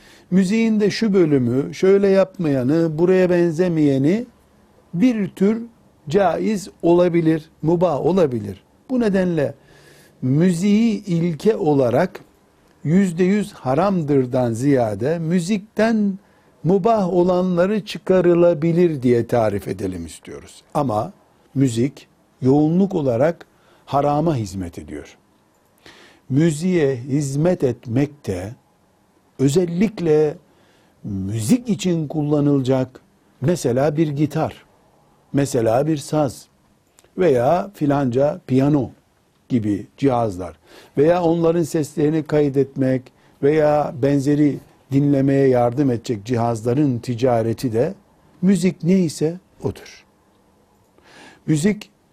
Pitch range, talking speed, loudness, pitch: 130-180 Hz, 80 wpm, -19 LUFS, 155 Hz